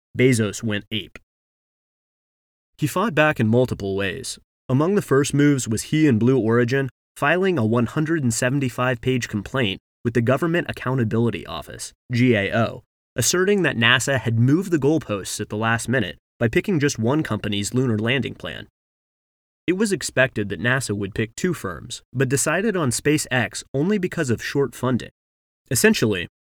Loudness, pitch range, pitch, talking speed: -21 LUFS, 110-145 Hz, 125 Hz, 150 wpm